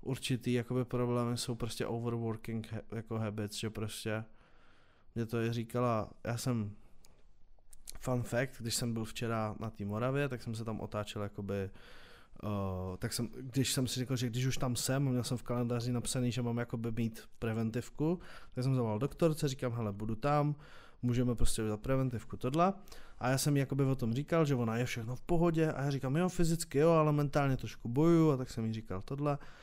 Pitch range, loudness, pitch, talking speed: 110-130 Hz, -35 LUFS, 120 Hz, 195 wpm